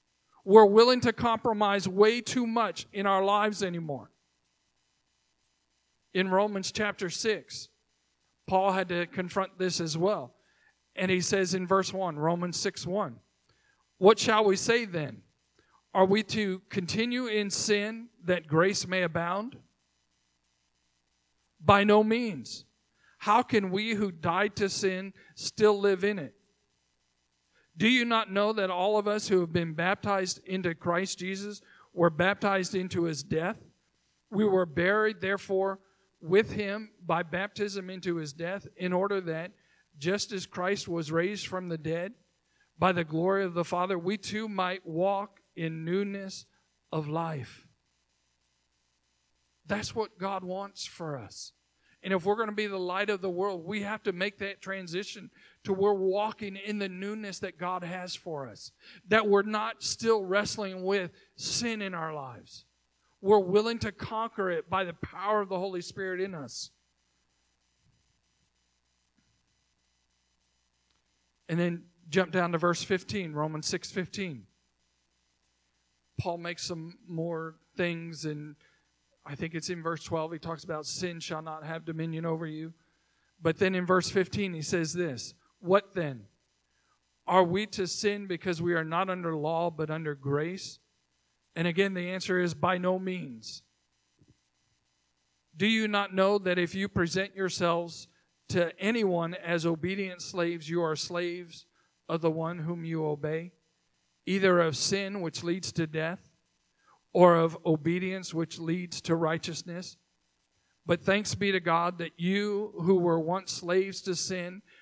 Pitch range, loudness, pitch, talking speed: 155-195 Hz, -29 LUFS, 180 Hz, 150 wpm